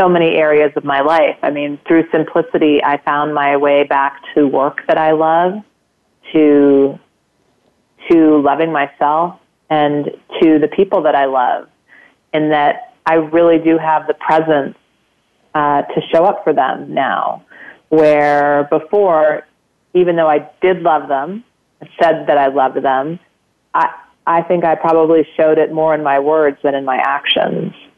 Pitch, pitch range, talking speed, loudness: 155 Hz, 145-165 Hz, 160 wpm, -13 LUFS